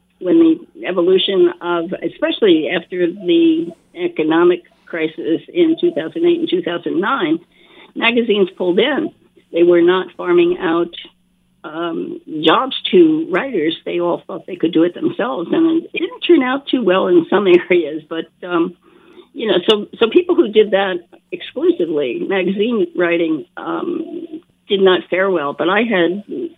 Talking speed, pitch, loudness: 145 wpm, 205 Hz, -16 LUFS